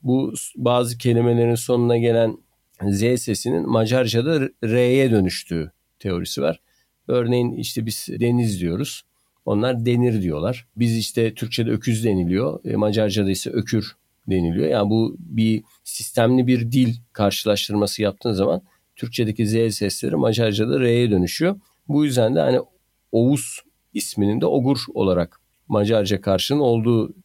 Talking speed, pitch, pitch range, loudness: 125 wpm, 115 Hz, 105-120 Hz, -21 LUFS